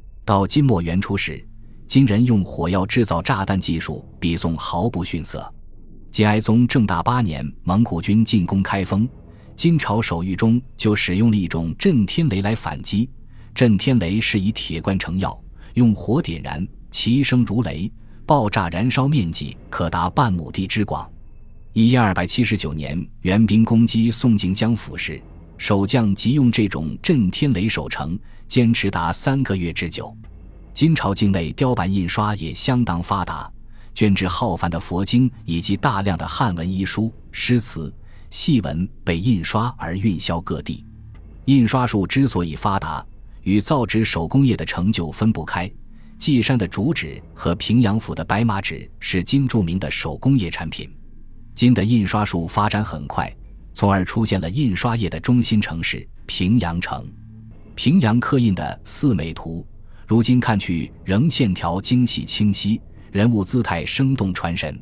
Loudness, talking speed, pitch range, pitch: -20 LUFS, 235 characters per minute, 85-115 Hz, 105 Hz